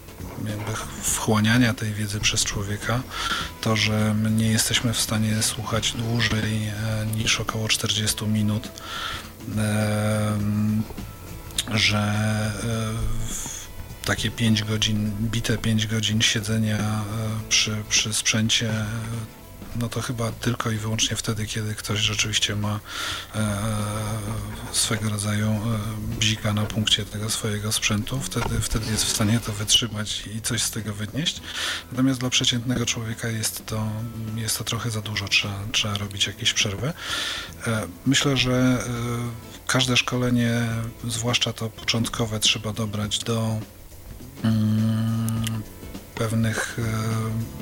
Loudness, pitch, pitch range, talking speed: -24 LUFS, 110 Hz, 105-115 Hz, 110 wpm